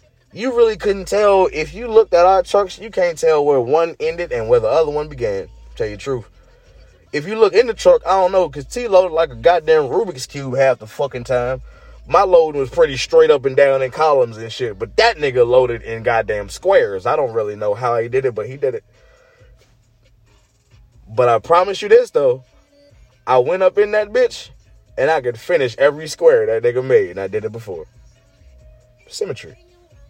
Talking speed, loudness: 210 wpm, -16 LUFS